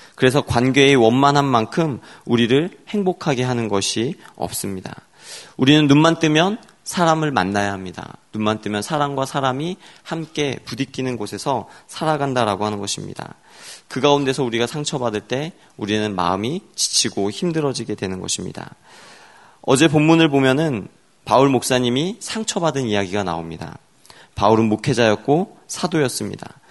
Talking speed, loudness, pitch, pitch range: 330 characters per minute, -19 LUFS, 130 Hz, 105-150 Hz